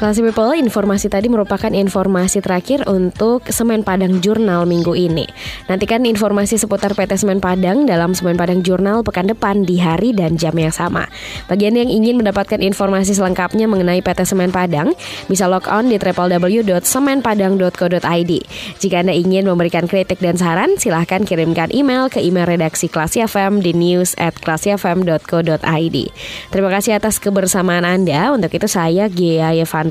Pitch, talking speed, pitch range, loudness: 190 Hz, 150 wpm, 175-210 Hz, -15 LUFS